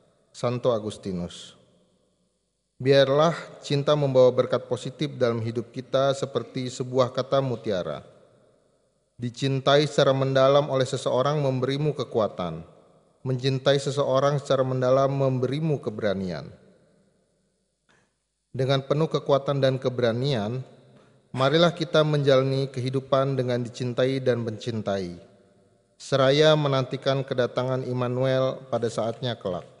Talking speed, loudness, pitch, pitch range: 95 wpm, -24 LUFS, 130 Hz, 120-140 Hz